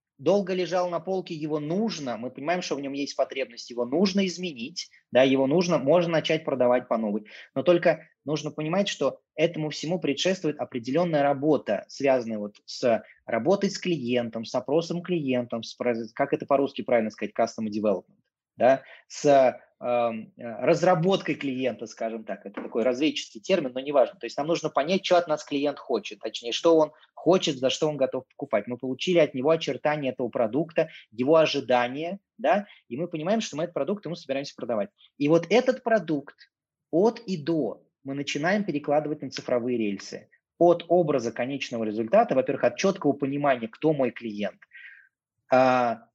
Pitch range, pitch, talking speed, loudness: 125-170 Hz, 150 Hz, 165 wpm, -26 LUFS